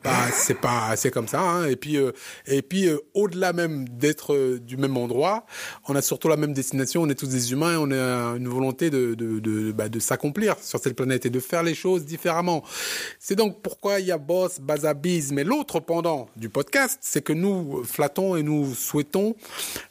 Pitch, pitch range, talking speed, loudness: 150 Hz, 130-175 Hz, 220 wpm, -24 LUFS